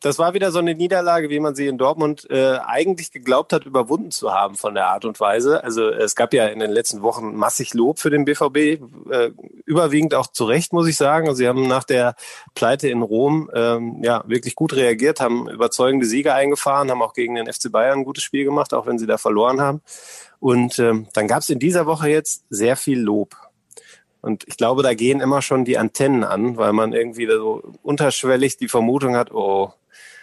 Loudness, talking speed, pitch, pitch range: -19 LUFS, 210 wpm, 135 Hz, 120-160 Hz